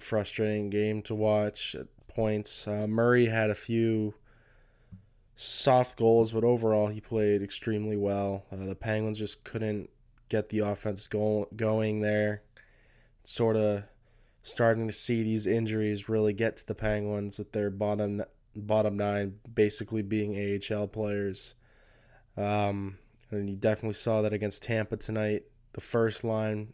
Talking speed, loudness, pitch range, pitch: 140 wpm, -30 LUFS, 105-110 Hz, 105 Hz